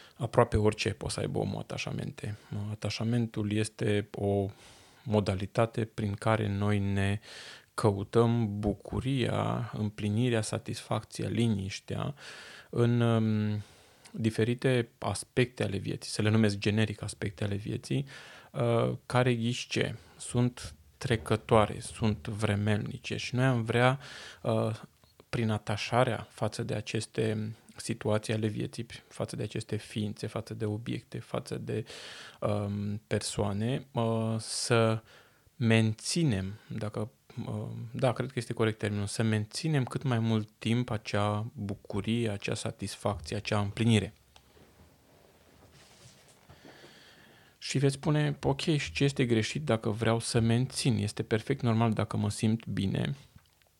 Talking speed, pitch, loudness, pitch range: 115 wpm, 110 Hz, -31 LUFS, 105-120 Hz